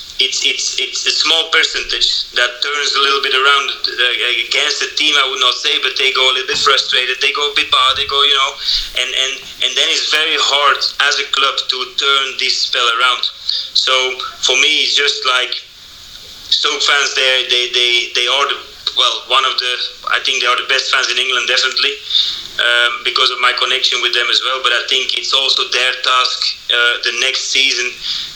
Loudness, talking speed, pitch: -12 LUFS, 205 wpm, 135 Hz